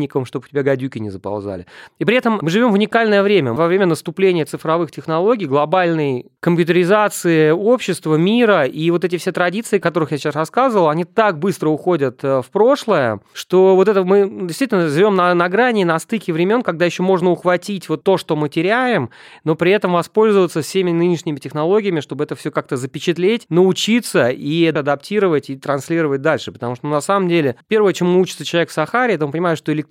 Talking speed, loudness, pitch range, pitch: 190 wpm, -16 LUFS, 150-190 Hz, 170 Hz